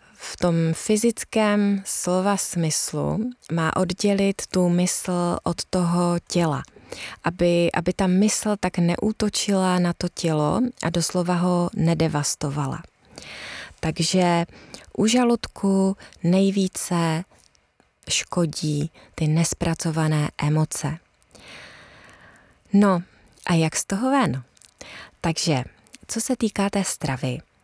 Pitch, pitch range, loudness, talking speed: 175 Hz, 165-195 Hz, -22 LUFS, 100 wpm